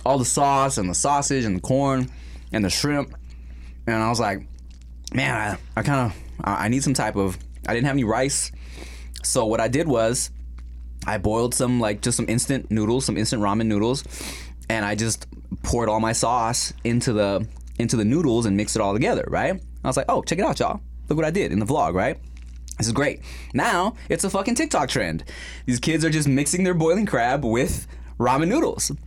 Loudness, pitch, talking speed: -23 LUFS, 110 Hz, 215 wpm